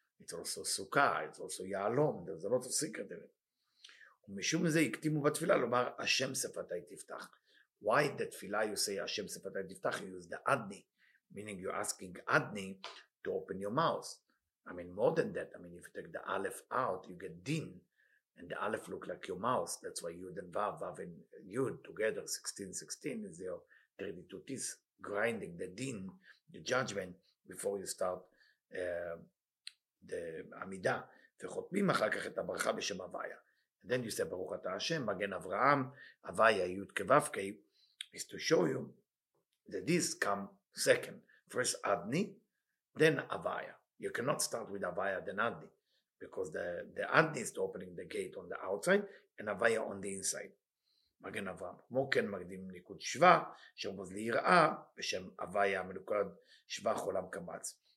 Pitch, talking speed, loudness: 200 Hz, 145 wpm, -37 LUFS